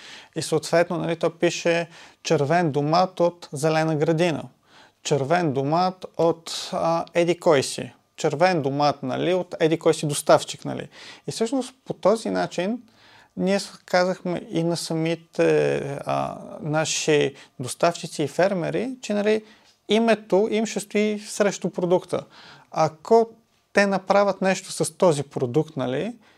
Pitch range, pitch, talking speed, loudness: 155-190 Hz, 170 Hz, 125 wpm, -23 LUFS